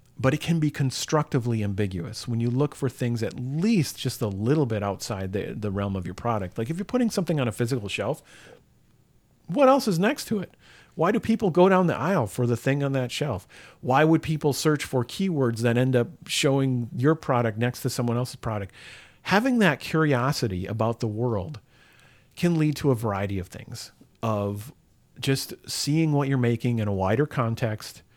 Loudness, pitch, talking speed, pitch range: -25 LUFS, 130 Hz, 195 wpm, 115-155 Hz